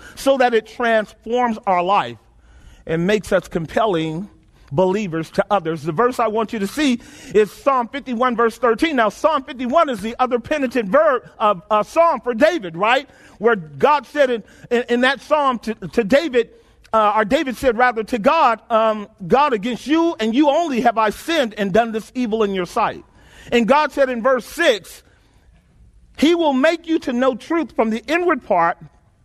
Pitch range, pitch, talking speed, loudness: 210-275 Hz, 235 Hz, 190 wpm, -18 LUFS